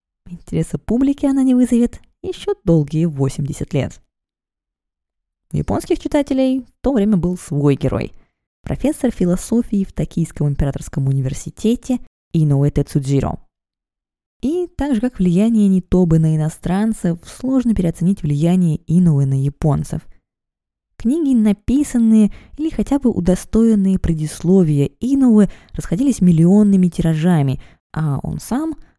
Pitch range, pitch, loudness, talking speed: 160-245 Hz, 185 Hz, -17 LUFS, 110 wpm